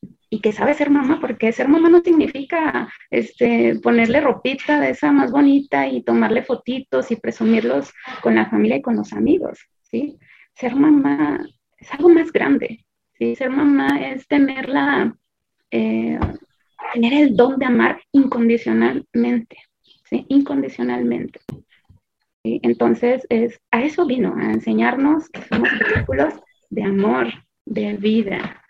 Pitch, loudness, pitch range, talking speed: 250 Hz, -18 LUFS, 200-285 Hz, 135 wpm